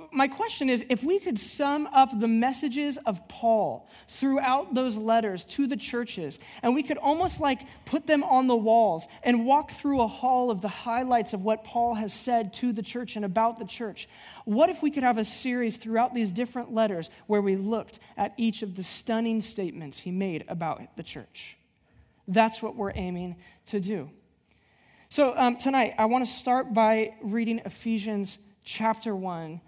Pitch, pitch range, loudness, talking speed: 230 Hz, 210-255 Hz, -27 LUFS, 185 wpm